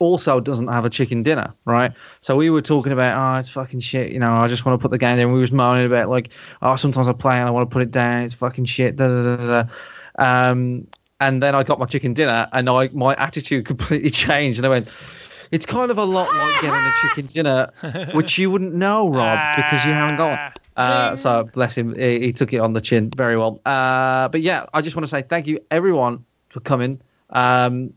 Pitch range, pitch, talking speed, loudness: 125-150 Hz, 130 Hz, 240 wpm, -18 LUFS